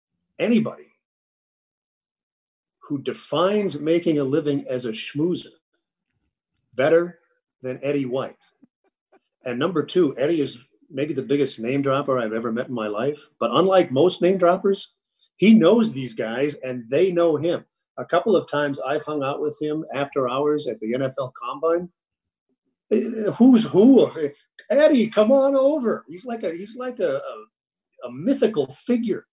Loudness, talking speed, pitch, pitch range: -21 LUFS, 150 wpm, 155 Hz, 135-210 Hz